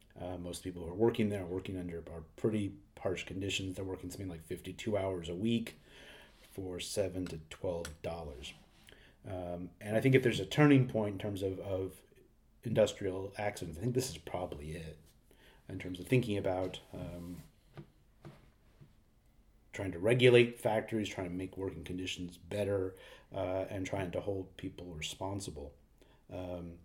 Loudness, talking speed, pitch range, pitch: -36 LUFS, 160 wpm, 90-105 Hz, 95 Hz